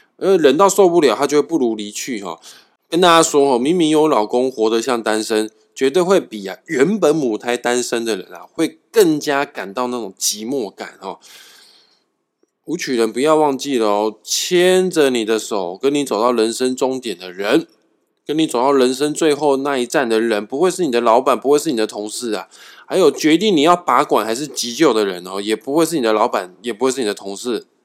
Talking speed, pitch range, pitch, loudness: 295 characters per minute, 110-155 Hz, 130 Hz, -17 LUFS